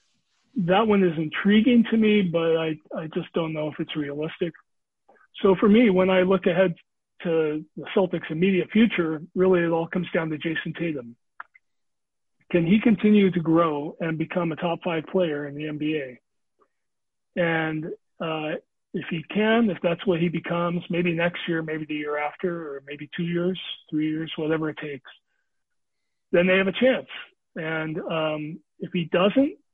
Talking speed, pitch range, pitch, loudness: 170 wpm, 155-190 Hz, 170 Hz, -24 LUFS